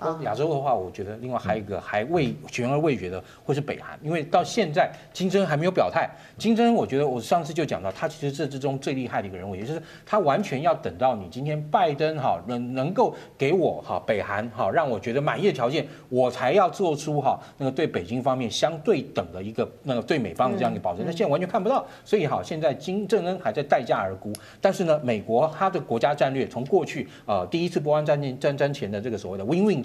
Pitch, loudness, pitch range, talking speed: 150 Hz, -25 LUFS, 125-175 Hz, 375 characters per minute